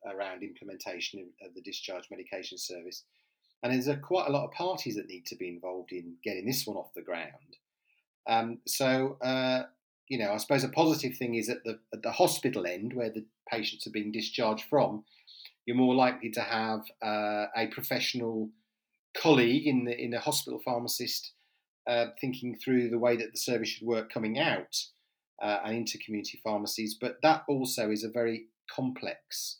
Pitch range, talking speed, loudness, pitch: 110-130 Hz, 180 wpm, -31 LUFS, 120 Hz